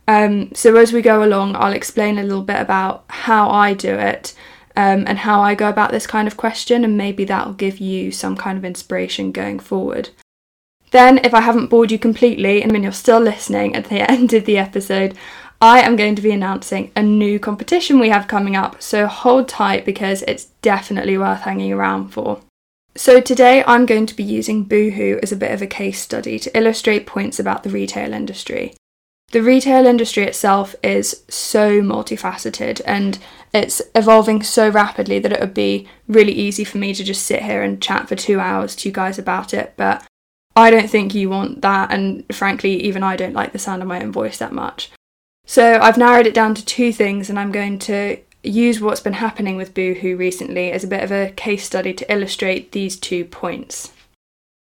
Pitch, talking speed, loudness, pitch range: 205 Hz, 205 wpm, -15 LUFS, 190-225 Hz